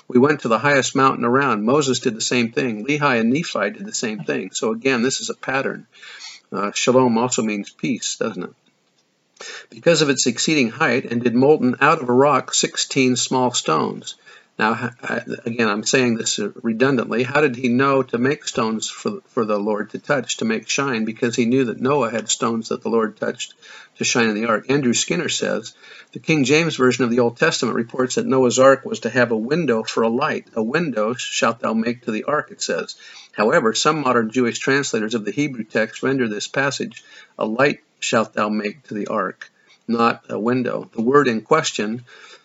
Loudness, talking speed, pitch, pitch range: -19 LUFS, 205 wpm, 125 Hz, 115-135 Hz